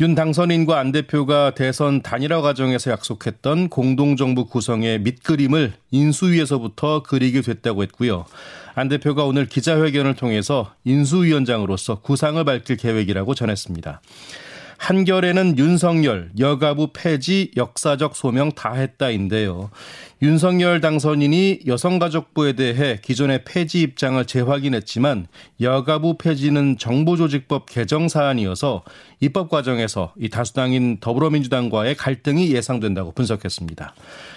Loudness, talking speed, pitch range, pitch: -19 LUFS, 330 characters per minute, 120-155 Hz, 140 Hz